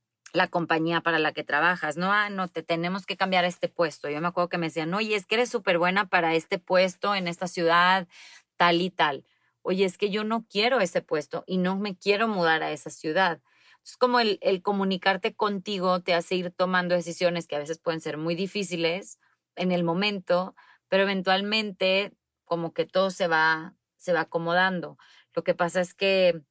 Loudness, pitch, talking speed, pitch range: -25 LUFS, 180 Hz, 200 wpm, 170-195 Hz